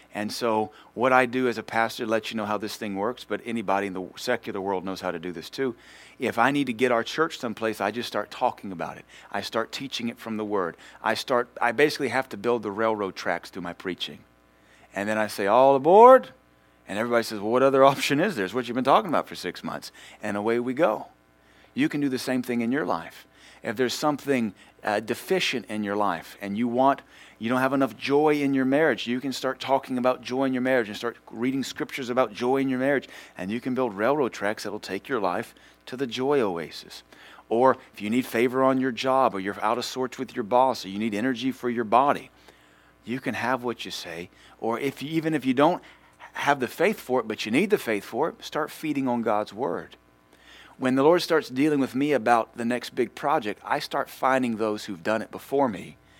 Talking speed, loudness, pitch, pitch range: 240 wpm, -25 LUFS, 120 Hz, 105-130 Hz